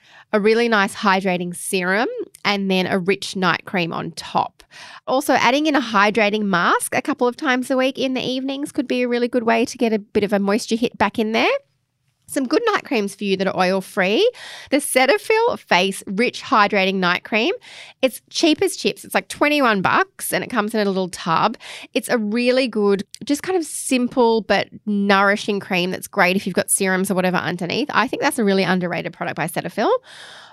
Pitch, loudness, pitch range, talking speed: 220 Hz, -19 LUFS, 195-260 Hz, 210 wpm